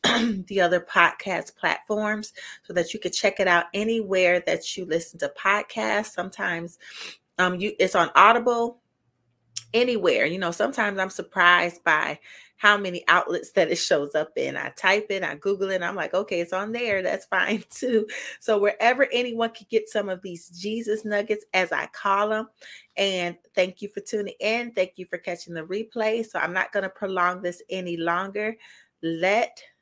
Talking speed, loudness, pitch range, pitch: 180 wpm, -24 LUFS, 180-215 Hz, 195 Hz